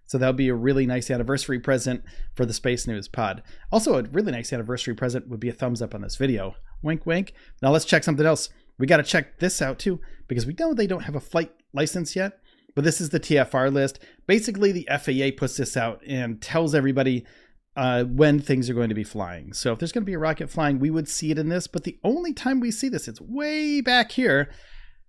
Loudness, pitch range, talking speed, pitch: -24 LUFS, 125-170 Hz, 240 wpm, 140 Hz